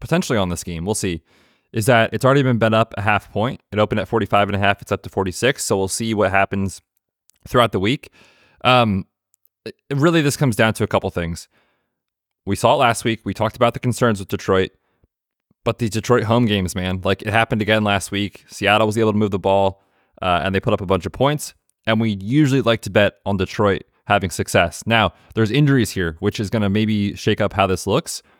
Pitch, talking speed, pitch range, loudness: 105 Hz, 230 wpm, 95-115 Hz, -19 LUFS